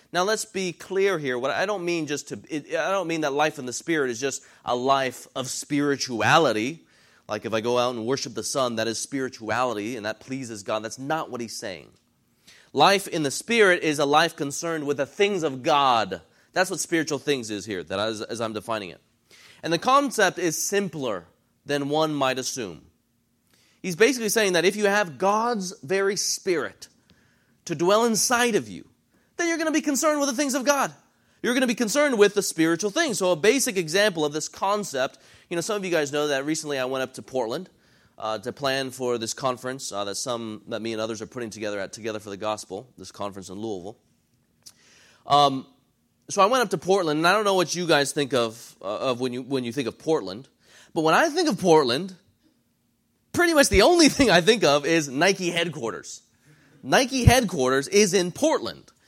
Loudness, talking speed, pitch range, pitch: -24 LUFS, 210 wpm, 130-200 Hz, 155 Hz